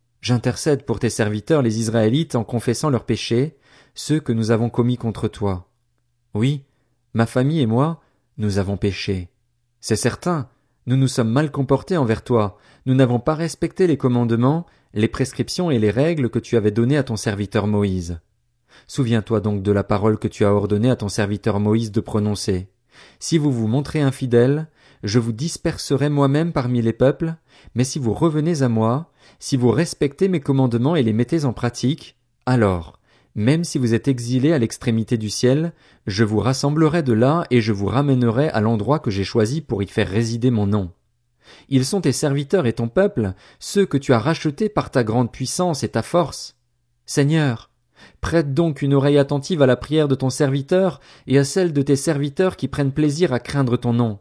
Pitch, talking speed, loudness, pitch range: 125 Hz, 190 wpm, -20 LUFS, 115-145 Hz